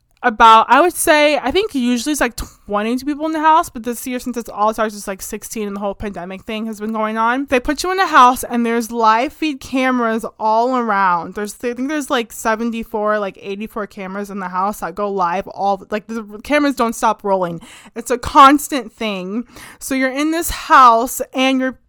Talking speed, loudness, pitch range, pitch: 215 wpm, -16 LUFS, 210-260 Hz, 230 Hz